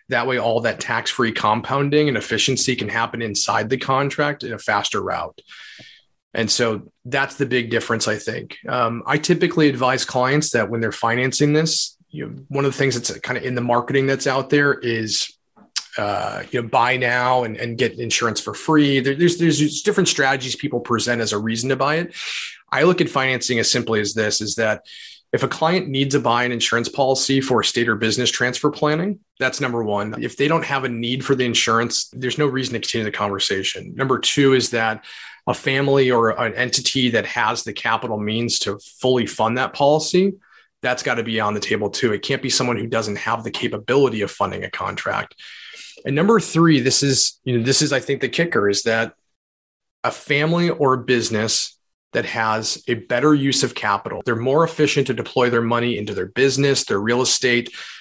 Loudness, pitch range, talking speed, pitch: -19 LUFS, 115-140 Hz, 205 wpm, 125 Hz